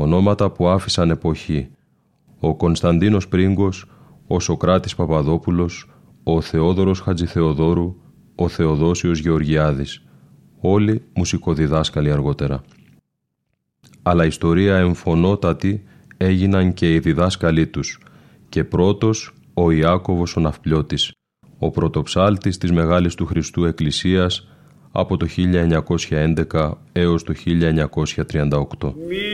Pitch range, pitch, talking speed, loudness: 80-95 Hz, 85 Hz, 95 wpm, -19 LUFS